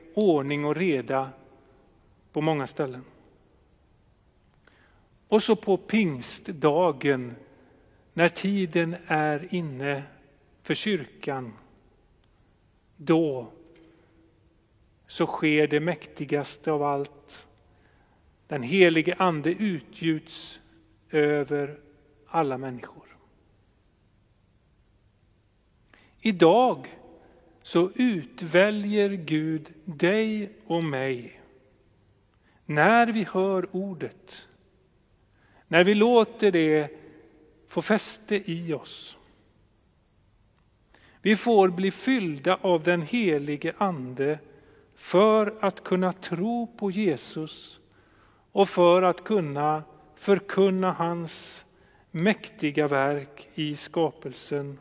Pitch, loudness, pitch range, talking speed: 155 Hz, -25 LUFS, 125-185 Hz, 80 wpm